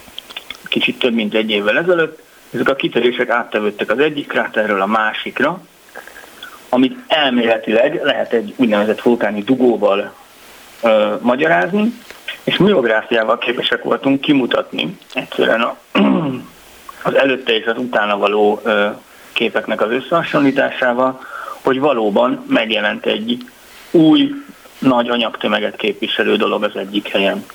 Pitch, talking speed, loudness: 125 Hz, 110 wpm, -16 LUFS